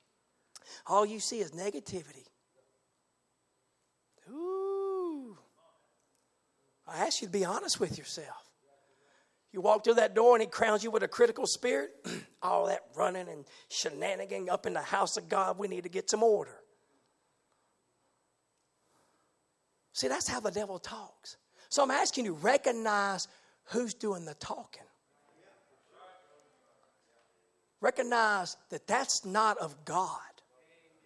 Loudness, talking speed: -31 LUFS, 125 wpm